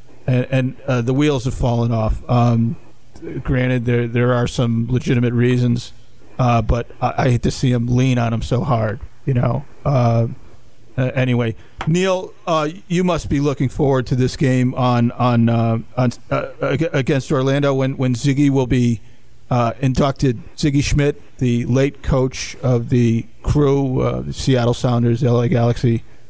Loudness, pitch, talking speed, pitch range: -18 LUFS, 125 Hz, 165 wpm, 120-135 Hz